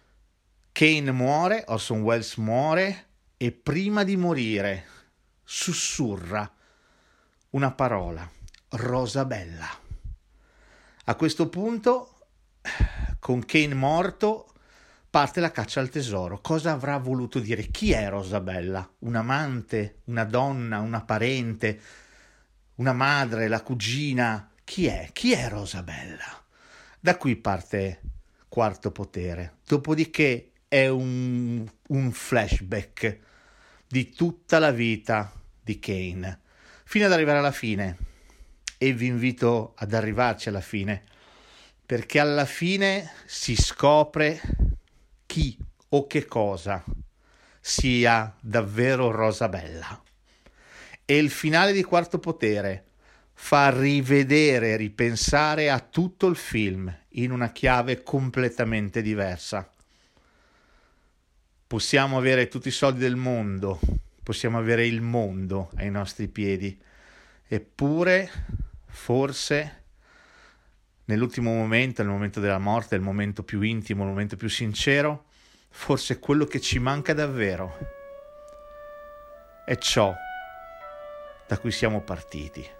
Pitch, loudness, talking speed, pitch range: 120 Hz, -25 LUFS, 105 wpm, 100-145 Hz